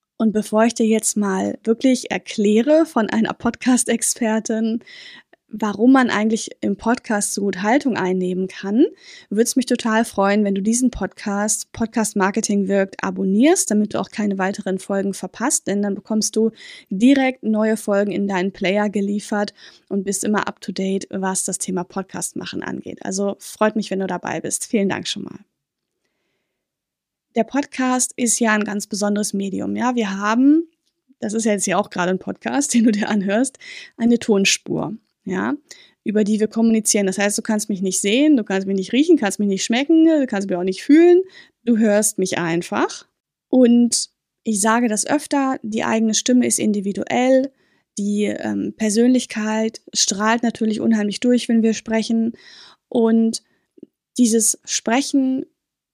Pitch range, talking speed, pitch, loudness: 200-245 Hz, 165 wpm, 220 Hz, -19 LUFS